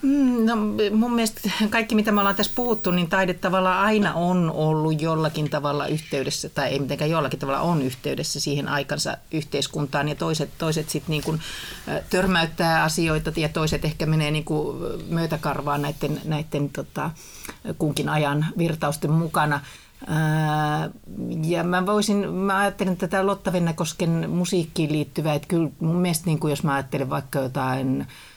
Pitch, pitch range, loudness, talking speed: 160 Hz, 150-185 Hz, -24 LUFS, 145 wpm